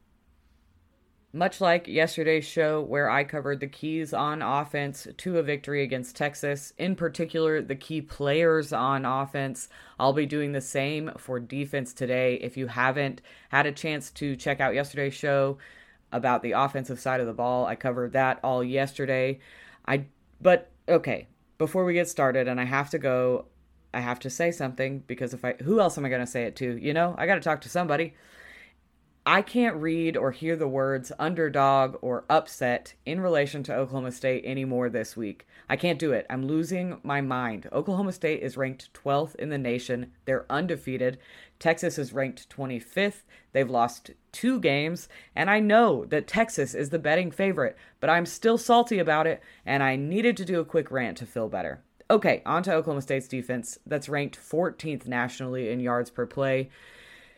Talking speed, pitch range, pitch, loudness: 185 wpm, 130-160 Hz, 140 Hz, -27 LUFS